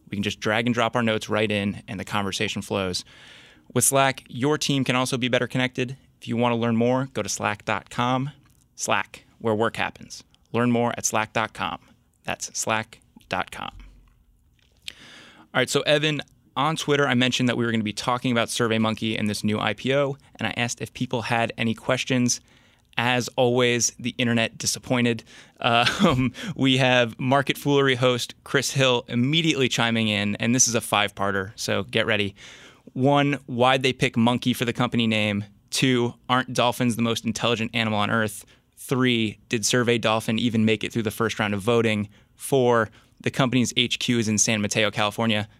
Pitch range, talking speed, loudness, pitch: 110-125 Hz, 180 wpm, -23 LUFS, 120 Hz